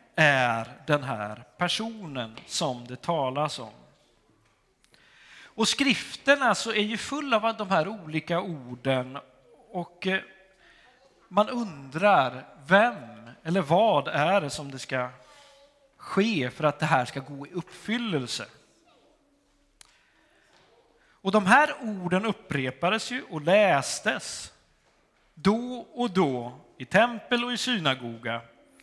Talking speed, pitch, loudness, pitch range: 115 wpm, 175 Hz, -26 LUFS, 135-225 Hz